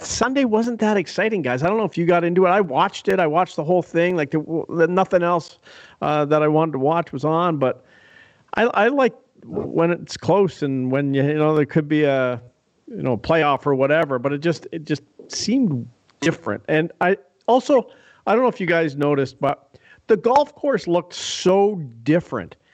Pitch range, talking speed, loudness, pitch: 145-185 Hz, 210 wpm, -20 LUFS, 165 Hz